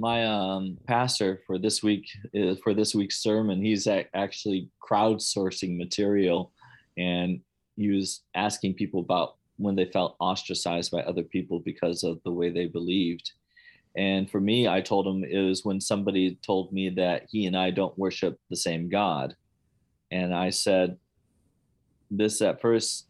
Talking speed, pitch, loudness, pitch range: 160 wpm, 95 Hz, -27 LUFS, 90-105 Hz